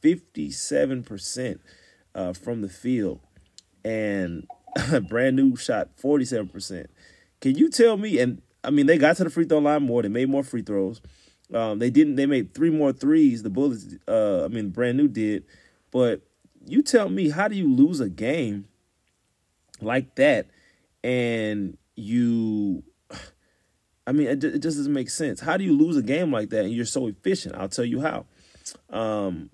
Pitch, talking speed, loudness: 125 Hz, 175 wpm, -24 LUFS